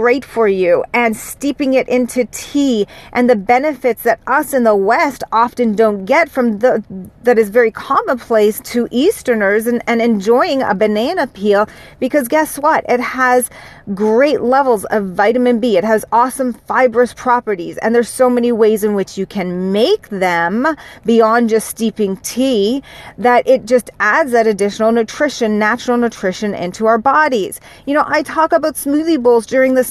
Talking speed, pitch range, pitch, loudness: 170 wpm, 215-260 Hz, 240 Hz, -14 LUFS